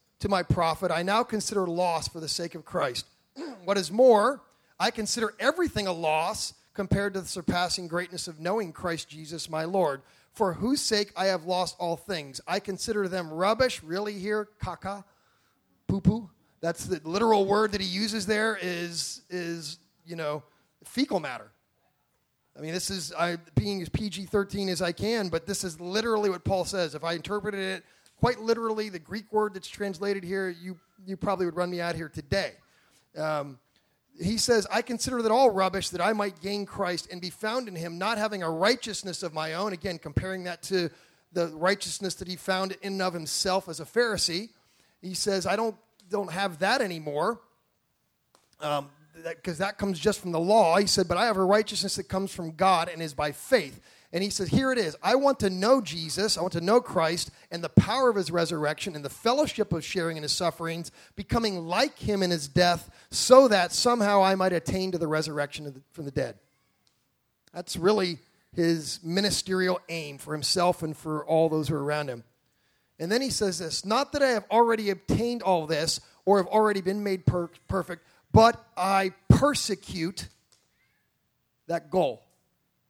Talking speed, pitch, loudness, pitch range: 190 wpm, 185 Hz, -27 LUFS, 165-205 Hz